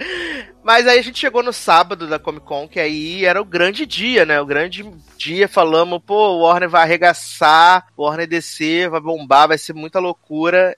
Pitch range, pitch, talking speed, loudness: 155-195 Hz, 175 Hz, 195 wpm, -15 LUFS